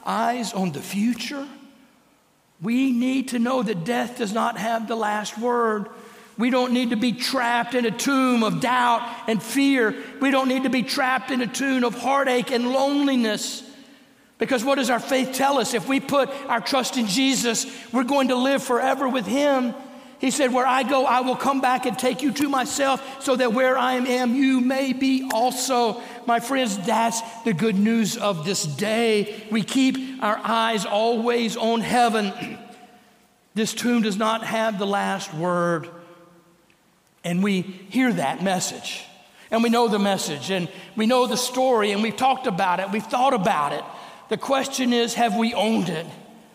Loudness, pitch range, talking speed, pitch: -22 LUFS, 220-260 Hz, 180 wpm, 240 Hz